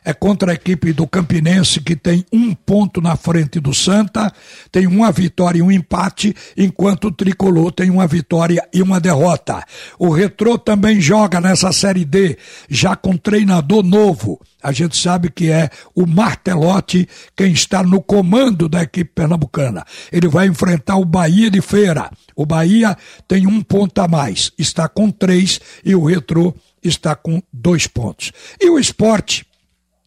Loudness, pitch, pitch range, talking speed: -14 LUFS, 180 Hz, 170-195 Hz, 160 wpm